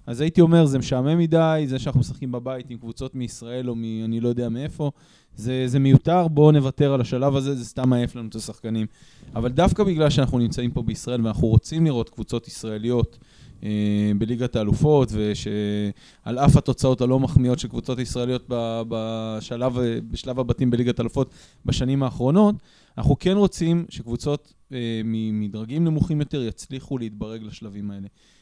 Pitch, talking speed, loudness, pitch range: 125 Hz, 160 wpm, -22 LUFS, 115-140 Hz